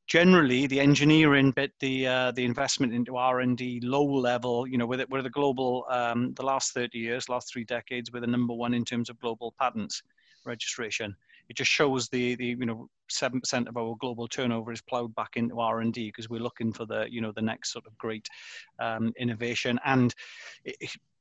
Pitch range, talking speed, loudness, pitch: 115-130 Hz, 215 wpm, -28 LUFS, 120 Hz